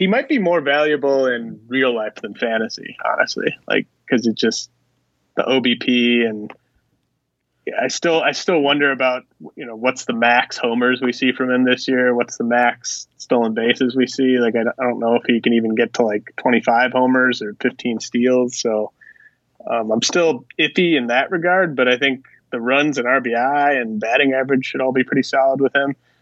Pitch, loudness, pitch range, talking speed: 125 Hz, -18 LUFS, 120-135 Hz, 195 wpm